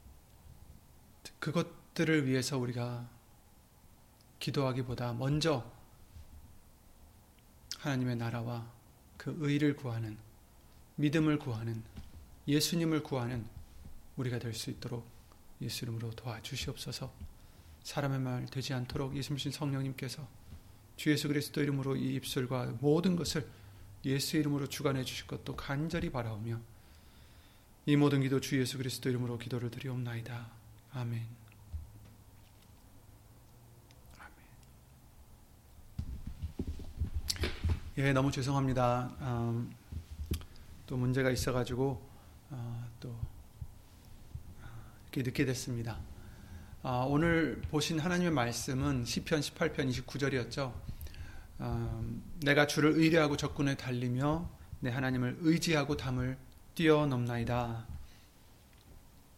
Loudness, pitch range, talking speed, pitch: -34 LUFS, 110-140 Hz, 230 characters per minute, 125 Hz